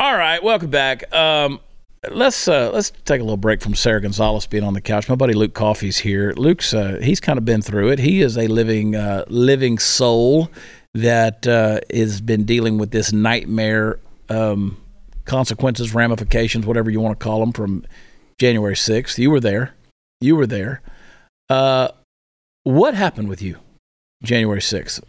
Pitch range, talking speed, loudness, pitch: 105-125 Hz, 170 wpm, -17 LUFS, 110 Hz